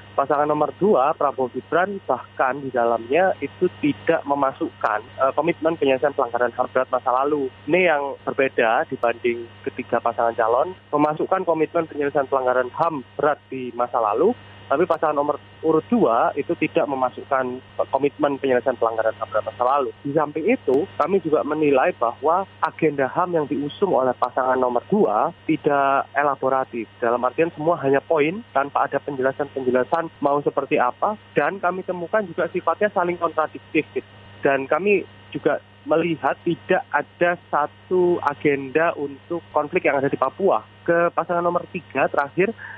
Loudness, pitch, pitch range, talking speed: -22 LUFS, 145 Hz, 130-165 Hz, 140 wpm